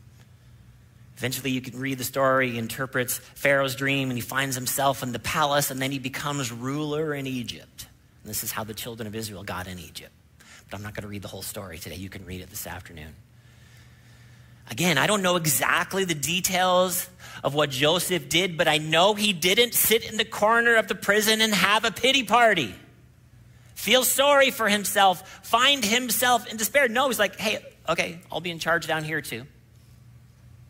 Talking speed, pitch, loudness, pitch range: 195 wpm, 135 Hz, -23 LUFS, 120-190 Hz